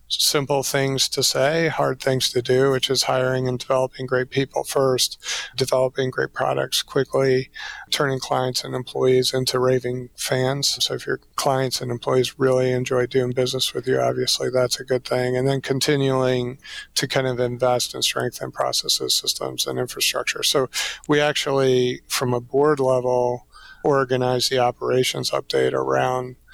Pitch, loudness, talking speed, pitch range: 130 Hz, -21 LUFS, 155 wpm, 125-135 Hz